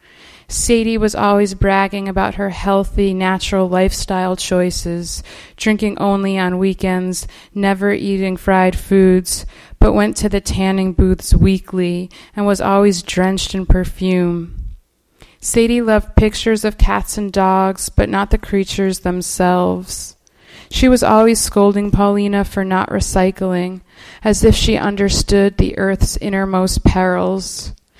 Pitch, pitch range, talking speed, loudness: 190 Hz, 180-200 Hz, 125 wpm, -15 LUFS